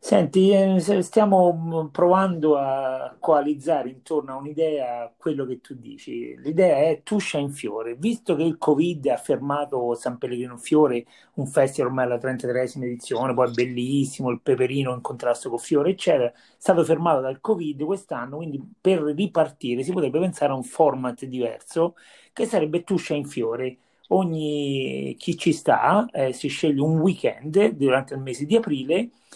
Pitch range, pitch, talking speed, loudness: 130-175 Hz, 150 Hz, 155 wpm, -23 LUFS